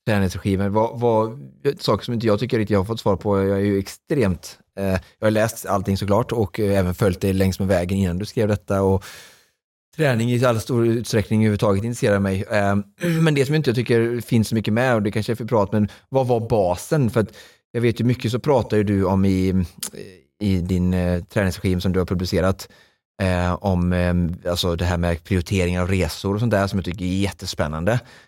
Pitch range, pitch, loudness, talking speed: 95-115 Hz, 100 Hz, -21 LUFS, 220 wpm